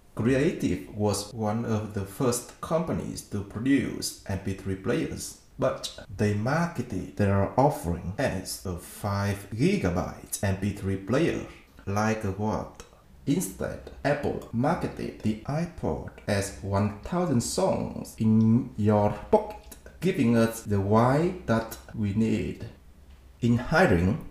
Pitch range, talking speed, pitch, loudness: 100-115 Hz, 110 wpm, 105 Hz, -28 LUFS